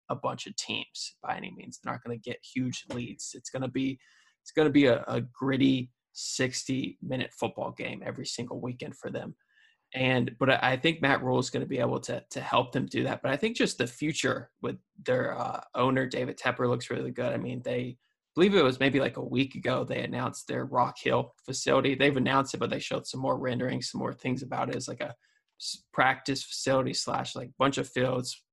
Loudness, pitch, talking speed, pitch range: -30 LUFS, 130 Hz, 220 wpm, 125-135 Hz